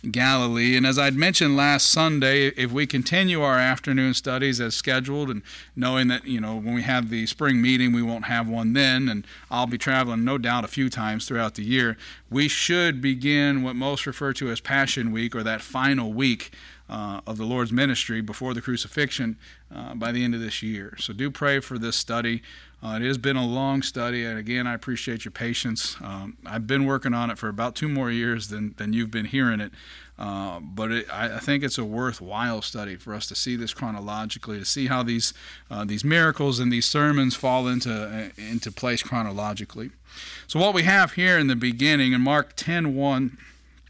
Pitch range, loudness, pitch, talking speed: 115-135 Hz, -23 LUFS, 125 Hz, 210 wpm